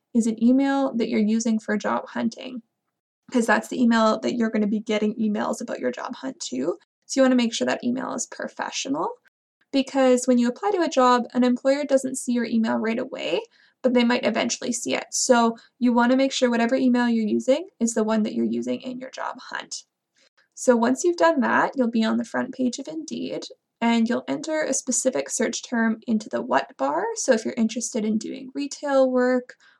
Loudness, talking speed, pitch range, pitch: -23 LUFS, 215 wpm, 230-265 Hz, 245 Hz